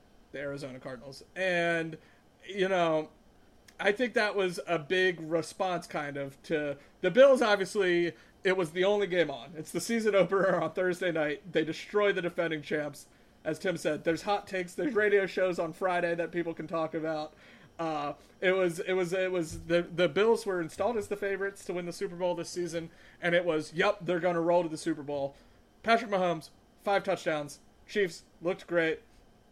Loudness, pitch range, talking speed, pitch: -30 LUFS, 160-190 Hz, 190 wpm, 175 Hz